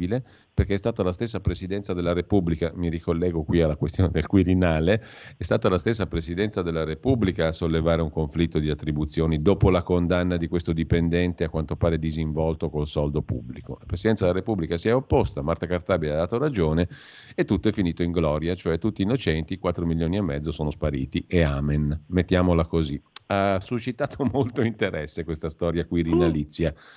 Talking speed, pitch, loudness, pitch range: 175 wpm, 85 Hz, -25 LUFS, 80-95 Hz